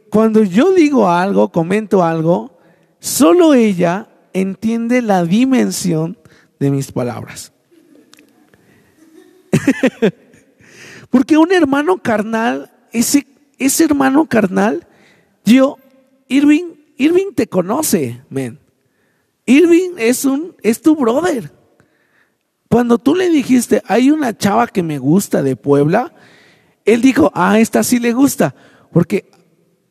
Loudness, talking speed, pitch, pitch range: -14 LUFS, 110 wpm, 230 Hz, 185-280 Hz